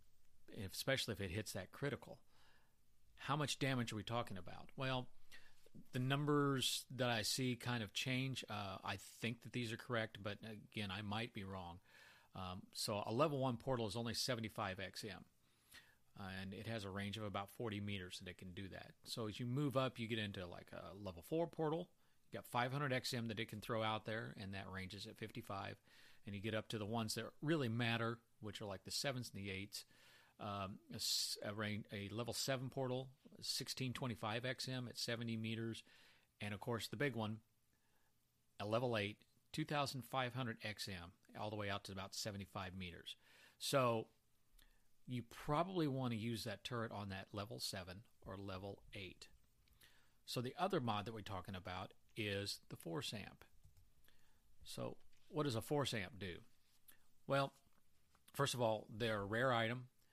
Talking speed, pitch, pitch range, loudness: 180 wpm, 115 Hz, 100-125 Hz, -44 LUFS